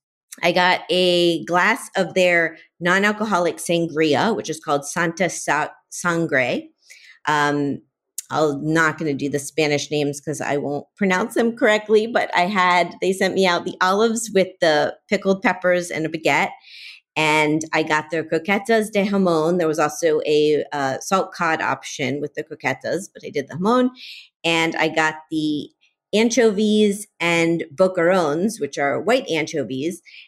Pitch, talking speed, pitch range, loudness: 170 Hz, 155 wpm, 155-195 Hz, -20 LUFS